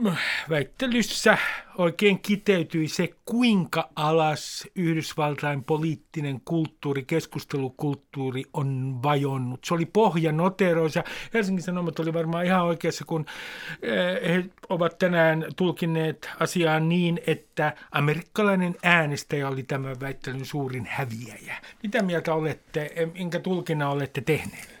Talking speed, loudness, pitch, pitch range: 105 wpm, -26 LUFS, 160 Hz, 145-175 Hz